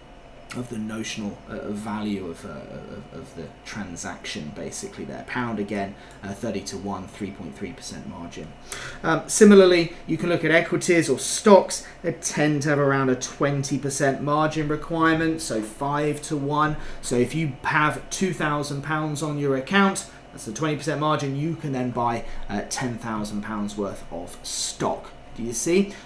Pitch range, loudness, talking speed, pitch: 115-155 Hz, -24 LUFS, 175 wpm, 140 Hz